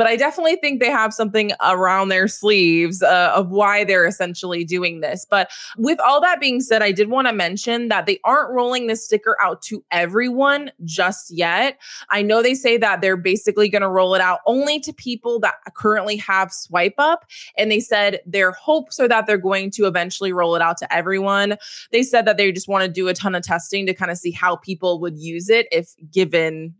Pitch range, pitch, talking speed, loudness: 180-235 Hz, 200 Hz, 220 wpm, -18 LUFS